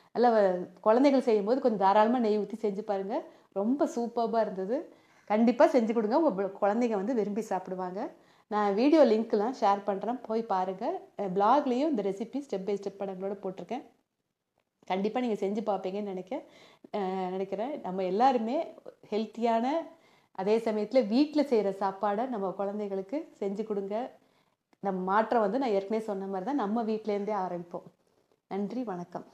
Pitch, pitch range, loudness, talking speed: 215 Hz, 195-245 Hz, -29 LUFS, 135 wpm